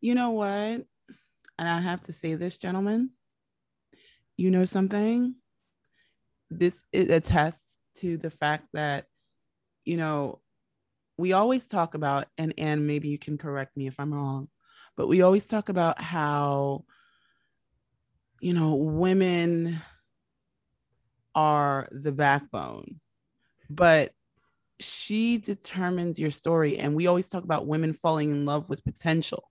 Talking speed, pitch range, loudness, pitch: 130 wpm, 145-185 Hz, -27 LUFS, 165 Hz